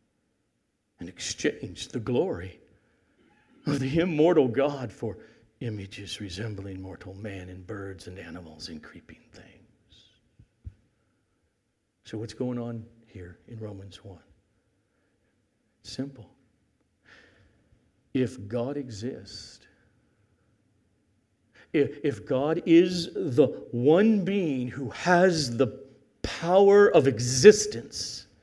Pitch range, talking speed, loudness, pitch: 100-135 Hz, 95 wpm, -25 LUFS, 115 Hz